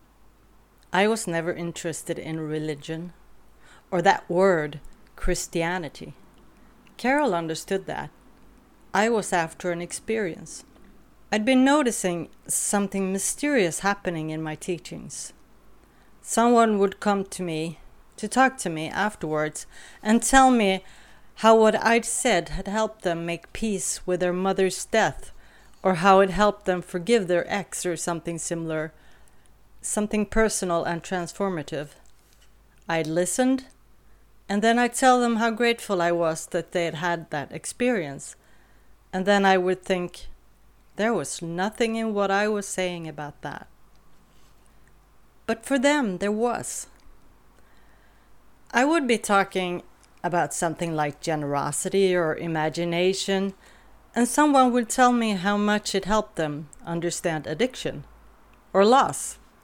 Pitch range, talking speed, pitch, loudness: 170-220 Hz, 130 wpm, 190 Hz, -24 LUFS